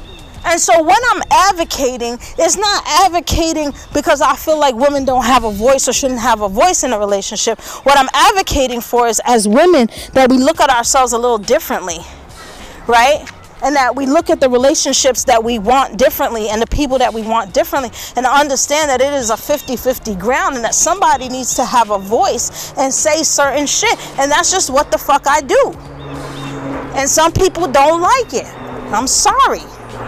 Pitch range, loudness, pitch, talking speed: 245-315 Hz, -13 LUFS, 275 Hz, 190 wpm